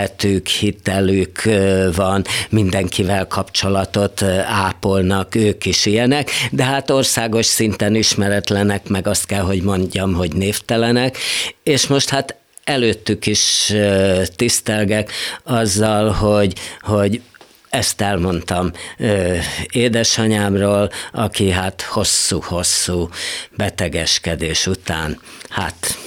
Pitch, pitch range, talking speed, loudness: 100 Hz, 95-110 Hz, 85 wpm, -17 LUFS